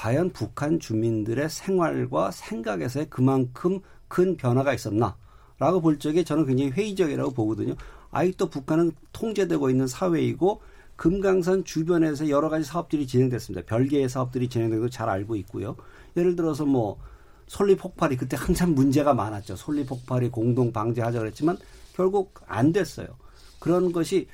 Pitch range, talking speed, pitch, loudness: 125-175 Hz, 360 characters per minute, 145 Hz, -25 LUFS